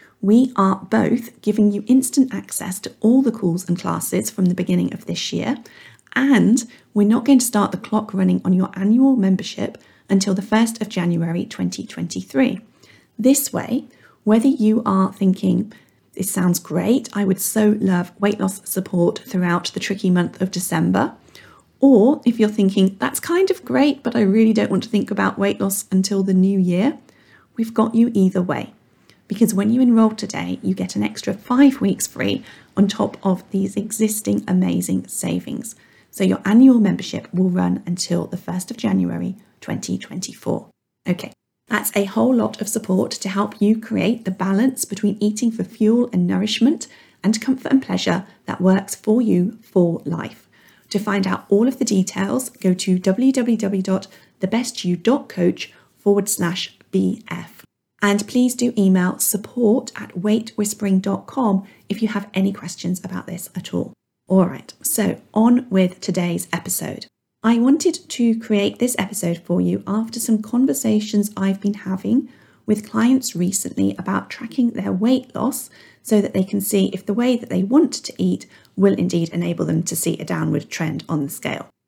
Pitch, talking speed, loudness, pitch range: 205 Hz, 170 wpm, -19 LUFS, 185-230 Hz